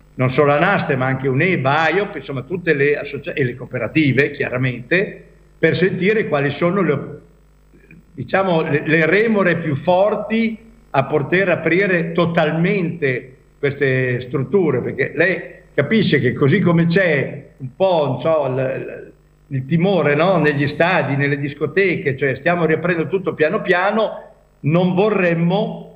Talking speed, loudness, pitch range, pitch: 140 wpm, -17 LUFS, 140-185 Hz, 160 Hz